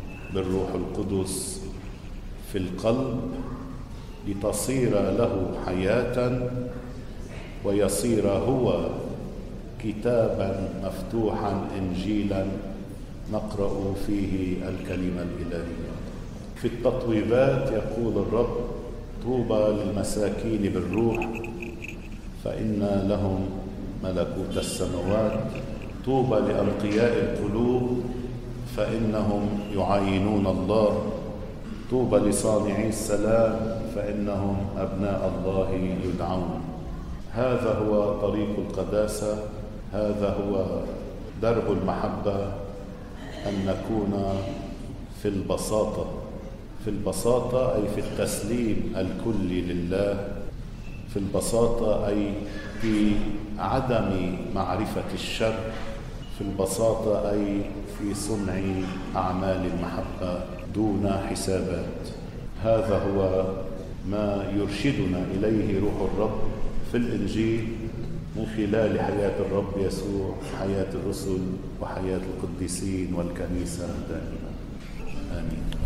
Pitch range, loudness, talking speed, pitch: 95-110 Hz, -27 LUFS, 75 wpm, 100 Hz